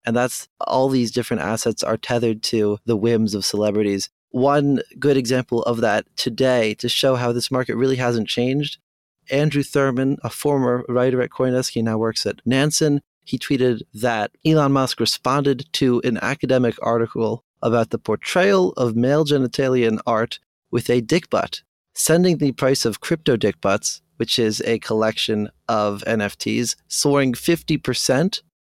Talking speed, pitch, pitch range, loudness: 155 wpm, 125 Hz, 115-140 Hz, -20 LUFS